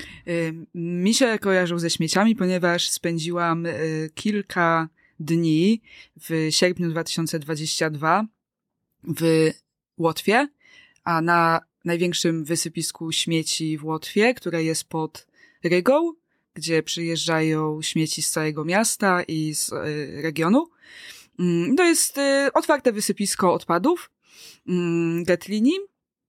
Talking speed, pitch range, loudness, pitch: 90 wpm, 160-205 Hz, -22 LUFS, 170 Hz